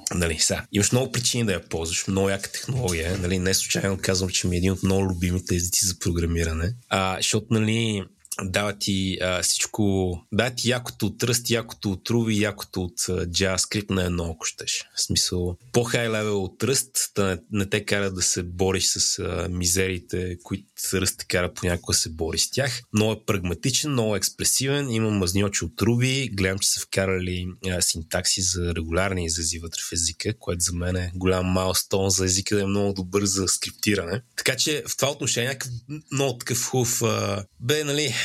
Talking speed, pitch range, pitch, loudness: 190 wpm, 90-115 Hz, 95 Hz, -24 LUFS